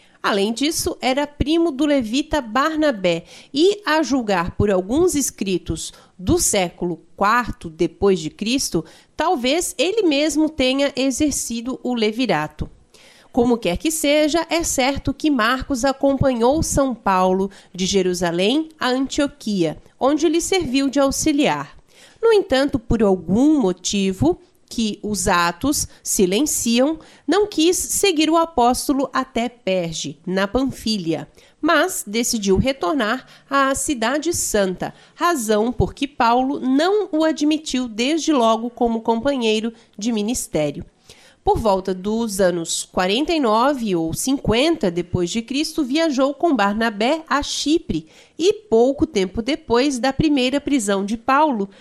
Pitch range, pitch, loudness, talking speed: 205-300 Hz, 260 Hz, -19 LUFS, 125 wpm